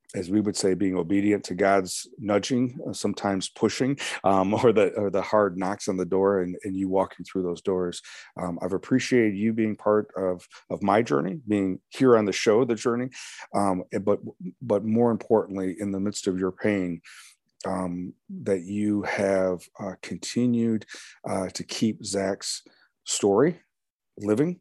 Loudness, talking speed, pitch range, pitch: -25 LUFS, 165 wpm, 95-110 Hz, 100 Hz